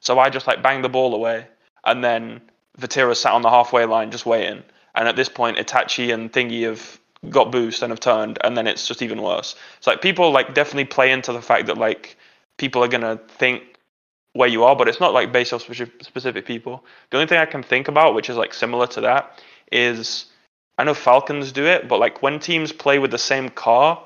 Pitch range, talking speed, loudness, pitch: 120-135 Hz, 225 wpm, -19 LUFS, 125 Hz